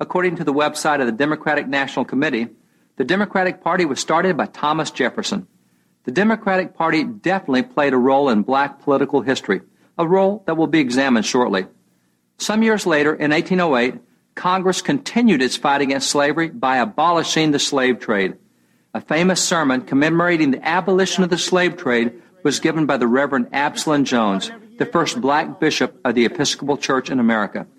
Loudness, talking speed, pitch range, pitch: -18 LUFS, 170 wpm, 135-185 Hz, 155 Hz